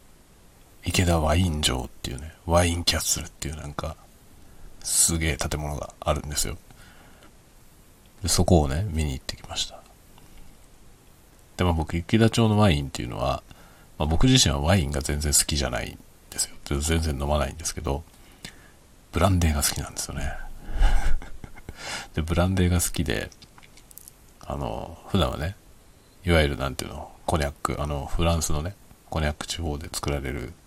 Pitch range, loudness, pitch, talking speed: 75-90 Hz, -25 LUFS, 80 Hz, 330 characters per minute